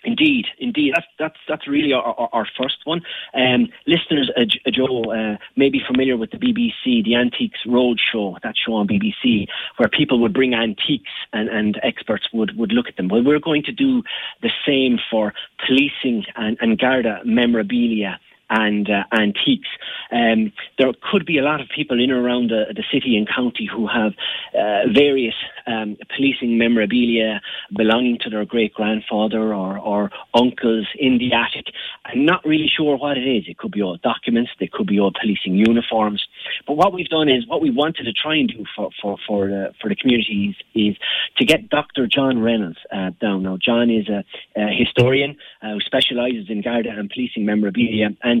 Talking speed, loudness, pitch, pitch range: 190 wpm, -19 LUFS, 120 Hz, 110-140 Hz